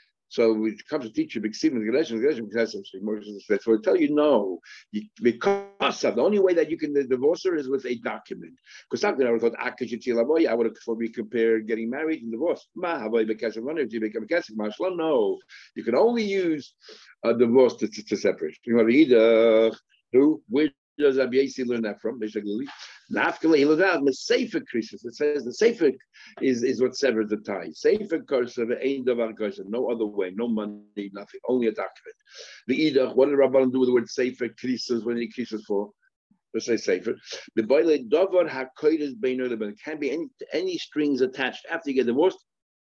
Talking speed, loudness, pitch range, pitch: 205 wpm, -24 LUFS, 115-155 Hz, 125 Hz